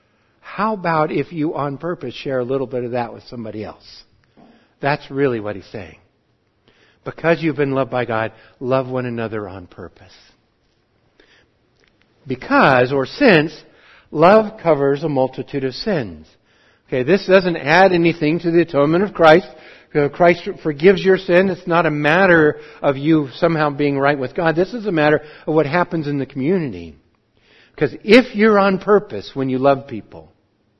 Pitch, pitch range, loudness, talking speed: 145 Hz, 120-170 Hz, -17 LUFS, 165 wpm